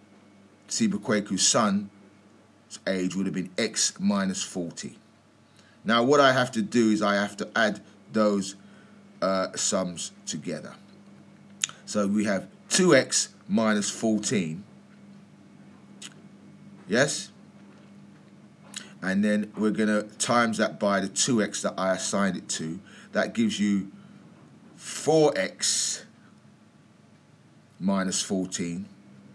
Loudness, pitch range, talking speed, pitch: -26 LUFS, 95-110 Hz, 105 wpm, 105 Hz